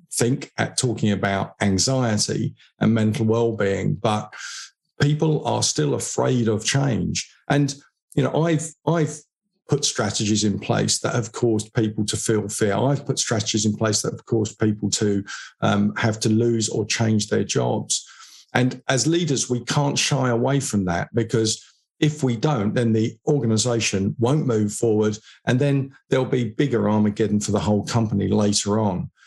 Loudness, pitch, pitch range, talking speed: -22 LUFS, 115 Hz, 105-135 Hz, 165 wpm